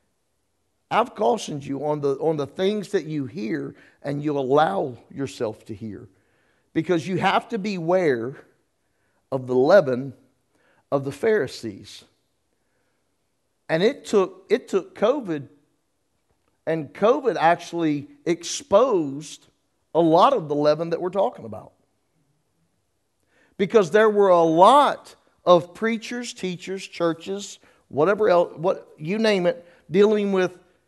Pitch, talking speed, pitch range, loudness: 160 Hz, 125 wpm, 135-185 Hz, -22 LUFS